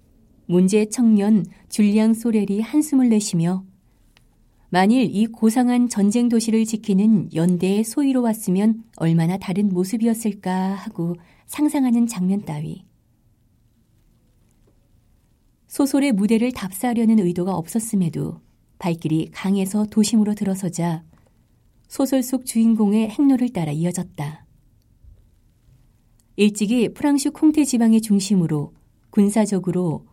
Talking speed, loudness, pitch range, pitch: 255 characters per minute, -20 LUFS, 160-225 Hz, 195 Hz